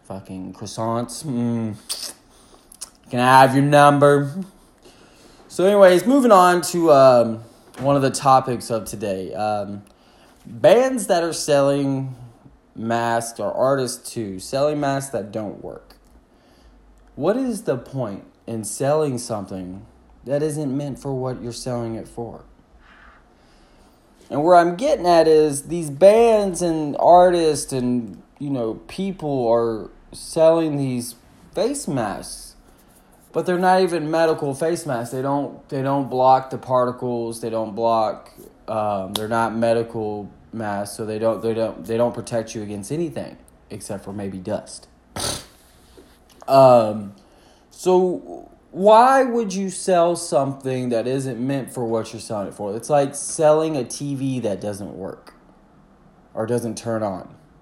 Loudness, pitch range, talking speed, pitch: -19 LUFS, 115-155 Hz, 140 wpm, 130 Hz